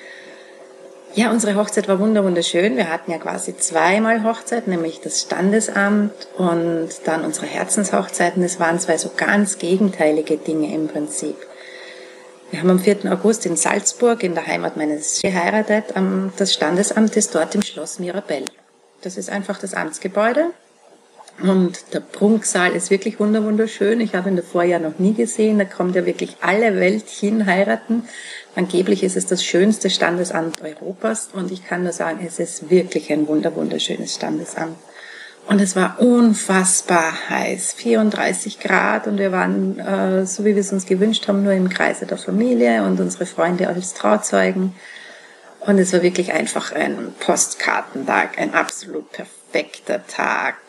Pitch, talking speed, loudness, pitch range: 190 Hz, 155 wpm, -19 LUFS, 170-210 Hz